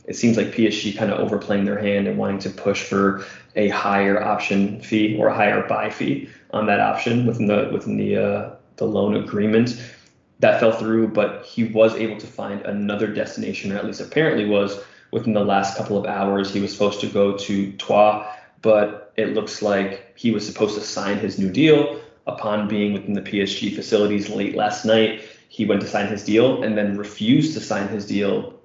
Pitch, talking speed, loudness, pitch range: 105 Hz, 205 wpm, -21 LUFS, 100-110 Hz